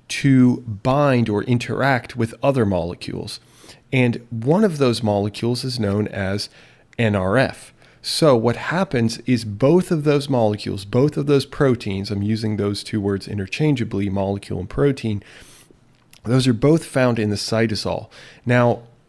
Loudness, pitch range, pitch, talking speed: -20 LUFS, 105-135 Hz, 115 Hz, 140 wpm